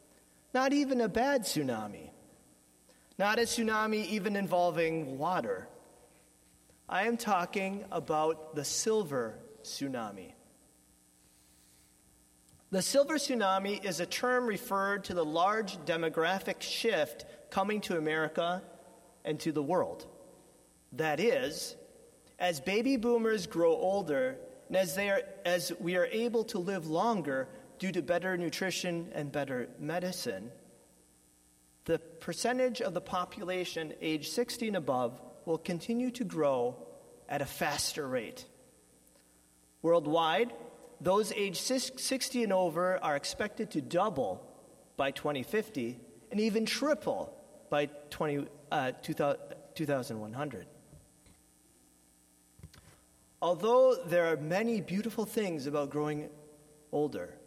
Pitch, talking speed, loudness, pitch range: 175 Hz, 115 wpm, -33 LUFS, 150-220 Hz